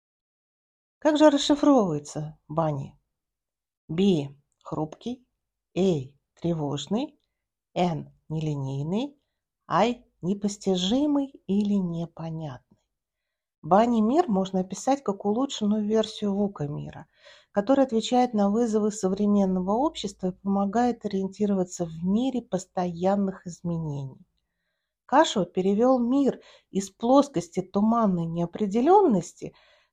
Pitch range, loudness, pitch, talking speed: 170-235 Hz, -25 LUFS, 195 Hz, 85 wpm